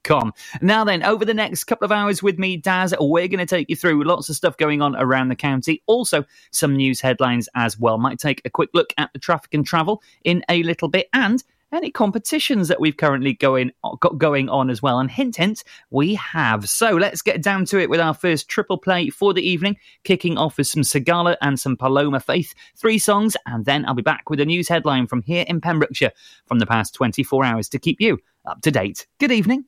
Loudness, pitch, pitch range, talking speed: -19 LUFS, 165 Hz, 135-195 Hz, 230 wpm